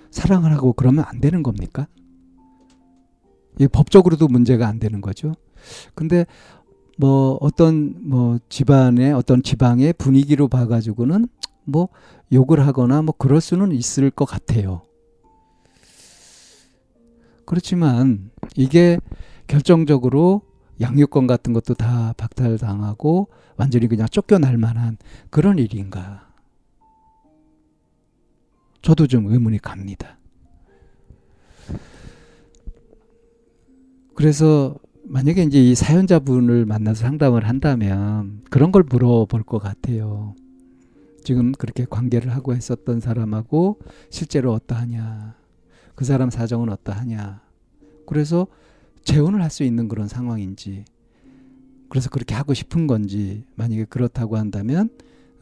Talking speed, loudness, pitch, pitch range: 240 characters per minute, -18 LUFS, 125 Hz, 110-155 Hz